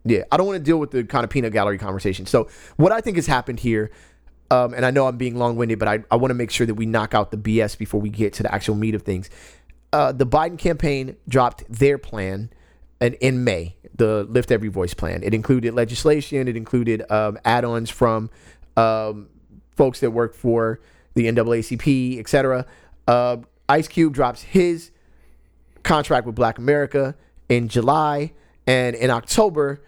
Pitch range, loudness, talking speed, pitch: 110-135 Hz, -21 LUFS, 195 wpm, 120 Hz